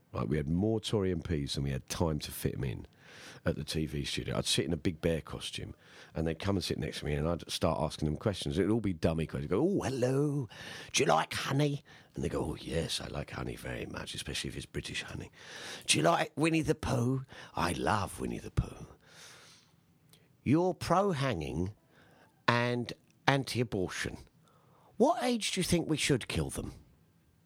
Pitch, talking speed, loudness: 105 Hz, 205 wpm, -33 LUFS